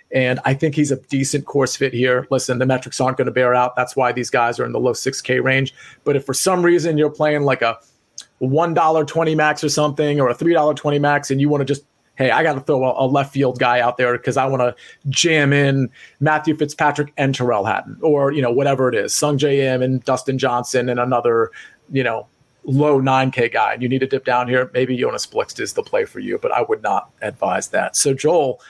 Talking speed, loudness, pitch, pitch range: 245 wpm, -18 LUFS, 135 Hz, 125-150 Hz